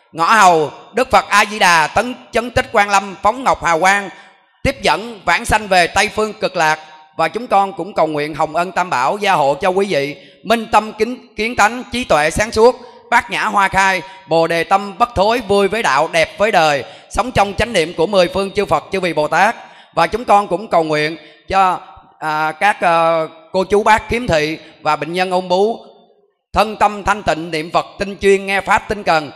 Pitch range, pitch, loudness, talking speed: 165-210 Hz, 195 Hz, -15 LUFS, 225 wpm